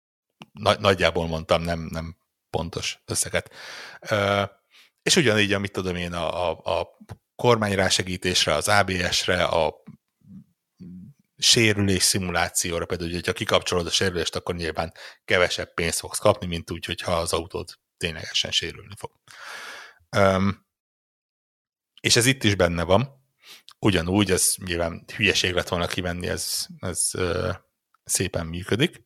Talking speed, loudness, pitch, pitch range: 115 wpm, -23 LUFS, 95 Hz, 85-110 Hz